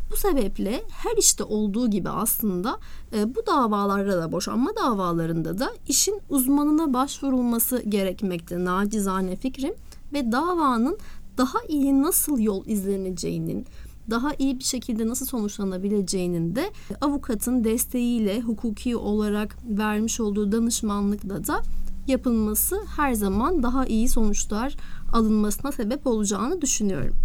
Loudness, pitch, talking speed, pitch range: -24 LUFS, 230 Hz, 110 wpm, 205-270 Hz